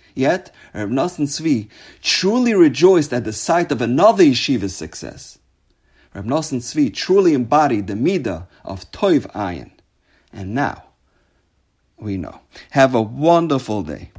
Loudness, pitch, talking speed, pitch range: -17 LUFS, 135 Hz, 125 wpm, 105-170 Hz